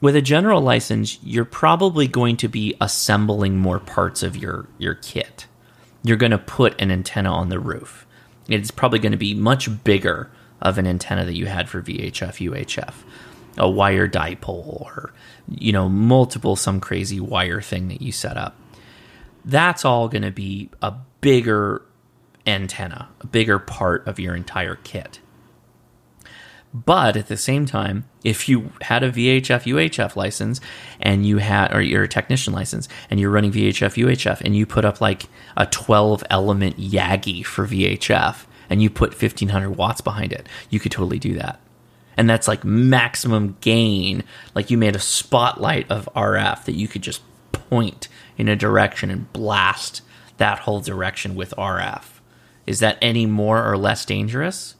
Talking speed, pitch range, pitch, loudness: 170 wpm, 95-120 Hz, 105 Hz, -20 LUFS